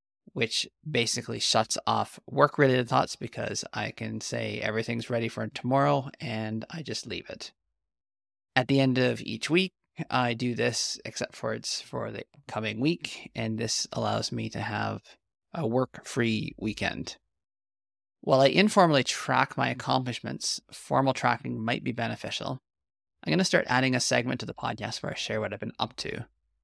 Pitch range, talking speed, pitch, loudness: 110-135 Hz, 170 wpm, 120 Hz, -28 LUFS